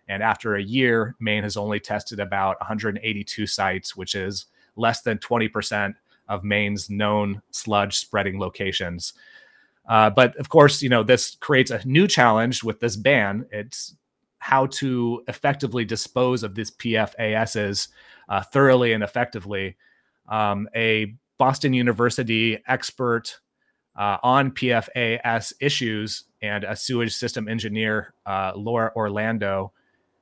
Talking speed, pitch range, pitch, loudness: 130 wpm, 105-120 Hz, 110 Hz, -22 LUFS